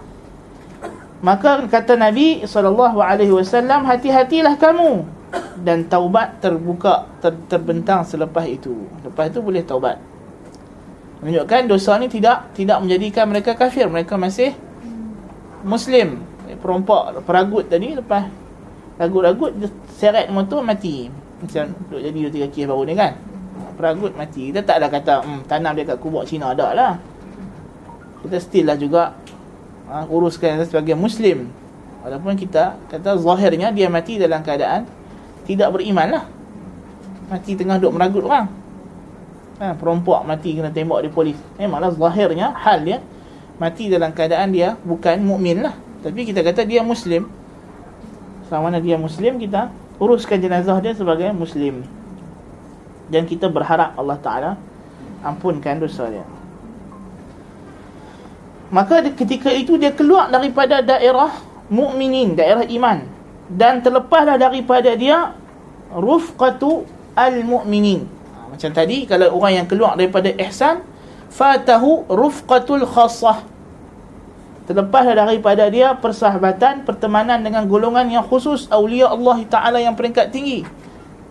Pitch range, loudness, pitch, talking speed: 165-240 Hz, -17 LUFS, 195 Hz, 120 wpm